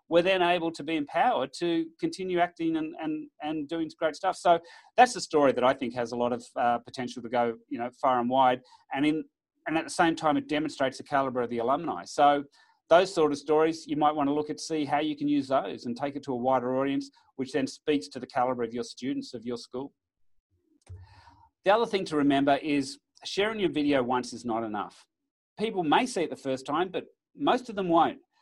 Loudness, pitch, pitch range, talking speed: -28 LUFS, 150 Hz, 130-170 Hz, 230 wpm